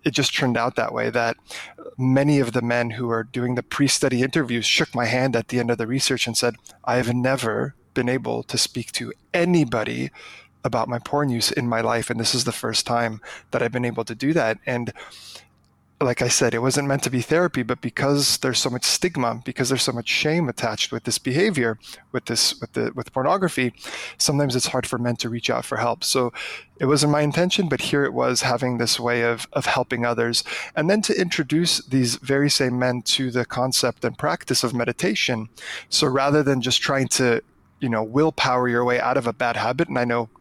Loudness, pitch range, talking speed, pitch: -22 LUFS, 120-140 Hz, 220 wpm, 125 Hz